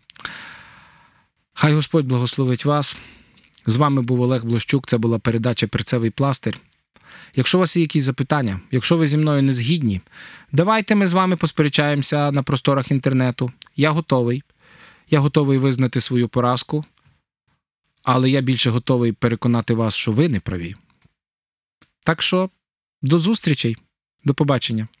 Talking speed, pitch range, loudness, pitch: 135 wpm, 120-150 Hz, -18 LUFS, 135 Hz